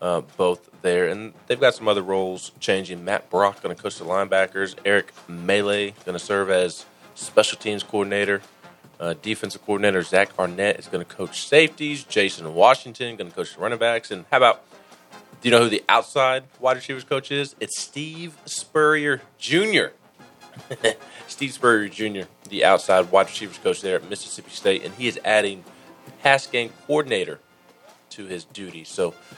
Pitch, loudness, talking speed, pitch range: 120 Hz, -22 LUFS, 170 wpm, 100-150 Hz